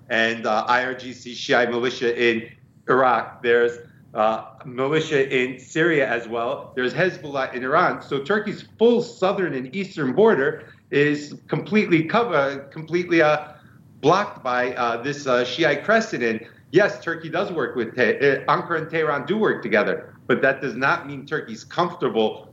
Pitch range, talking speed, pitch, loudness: 125-165 Hz, 150 wpm, 140 Hz, -22 LUFS